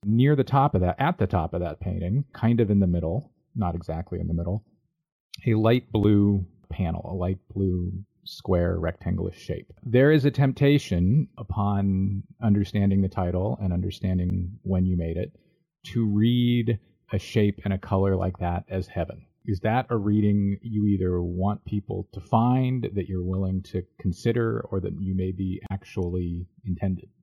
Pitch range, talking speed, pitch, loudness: 90-115 Hz, 170 wpm, 100 Hz, -26 LUFS